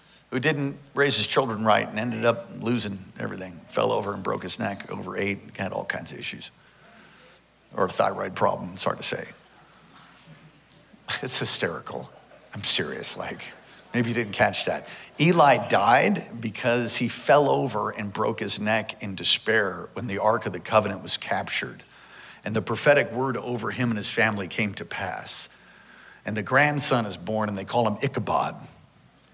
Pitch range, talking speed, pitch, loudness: 105-120 Hz, 175 wpm, 115 Hz, -25 LUFS